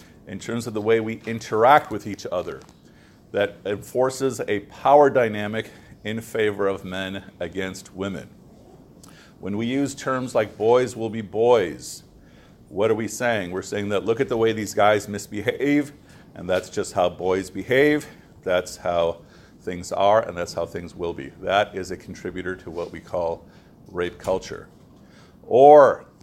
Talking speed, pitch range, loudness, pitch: 160 wpm, 95-115 Hz, -22 LUFS, 105 Hz